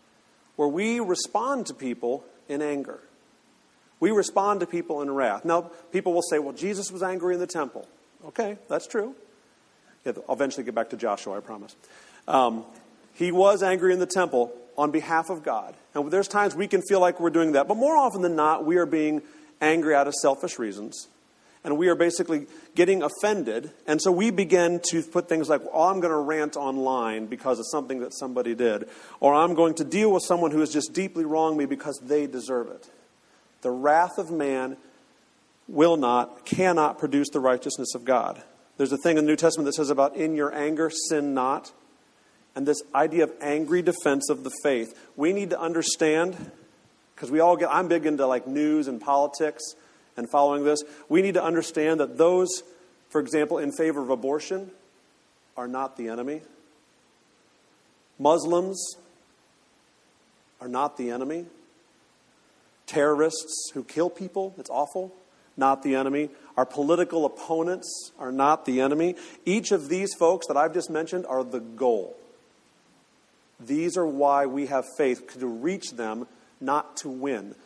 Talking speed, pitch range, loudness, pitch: 175 wpm, 140-175 Hz, -25 LUFS, 155 Hz